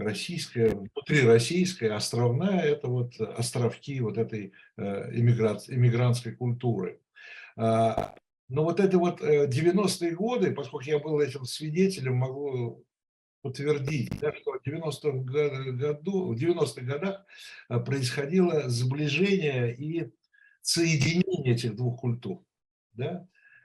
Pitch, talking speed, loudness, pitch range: 145 Hz, 105 wpm, -28 LUFS, 120-170 Hz